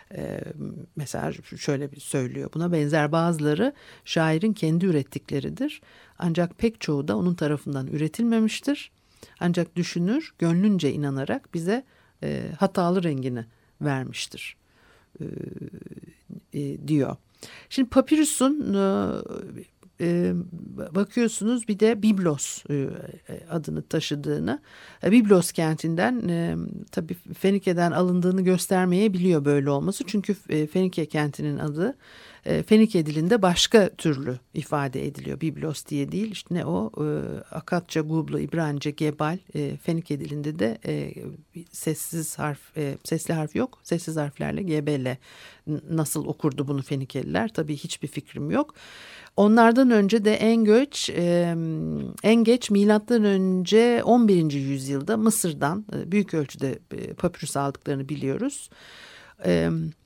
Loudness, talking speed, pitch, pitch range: -24 LUFS, 105 wpm, 170 Hz, 150-205 Hz